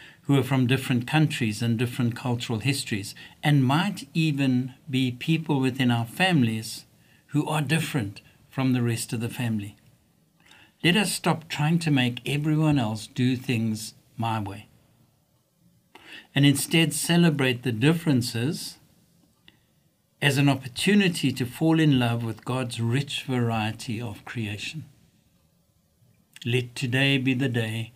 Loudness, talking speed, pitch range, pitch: -25 LUFS, 130 wpm, 120-150 Hz, 130 Hz